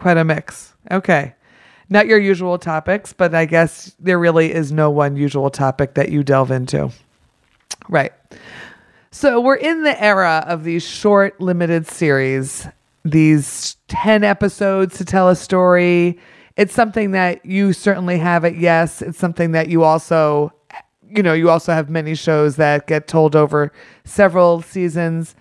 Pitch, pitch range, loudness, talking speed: 170 Hz, 155-190 Hz, -16 LUFS, 155 wpm